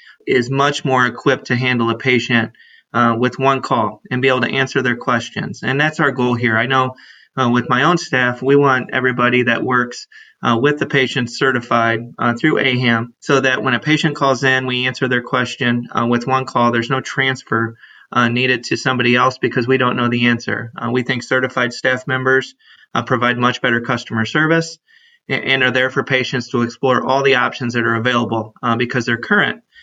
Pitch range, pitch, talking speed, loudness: 120-130 Hz, 125 Hz, 205 wpm, -16 LUFS